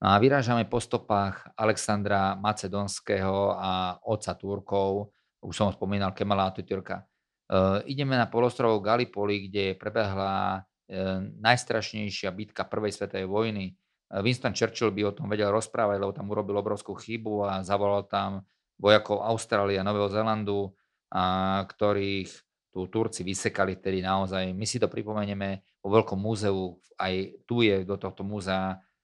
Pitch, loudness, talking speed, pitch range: 100 Hz, -28 LUFS, 140 wpm, 95-105 Hz